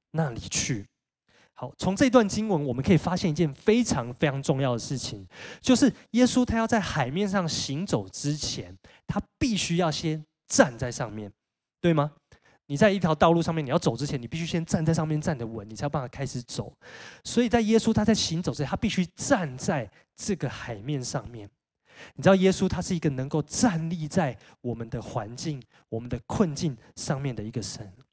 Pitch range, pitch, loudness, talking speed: 125-185 Hz, 155 Hz, -26 LUFS, 290 characters per minute